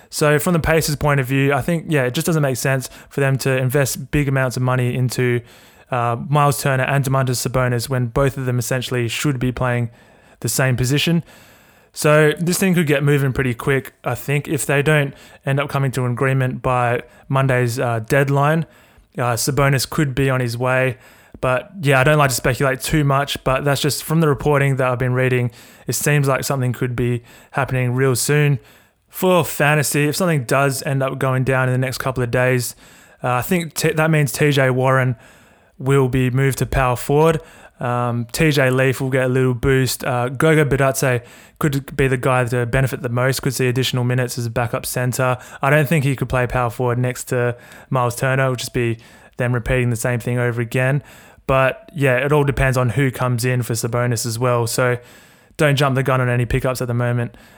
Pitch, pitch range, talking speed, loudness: 130 Hz, 125-140 Hz, 210 wpm, -18 LUFS